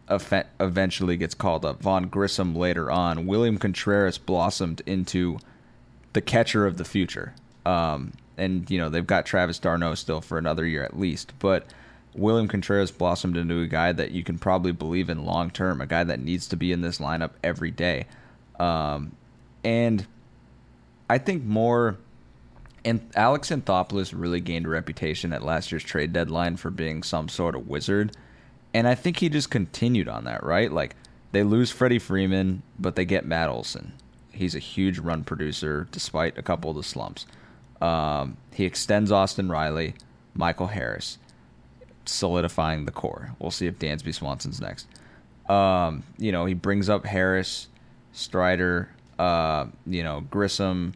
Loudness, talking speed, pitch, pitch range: -26 LUFS, 165 wpm, 90 Hz, 80-100 Hz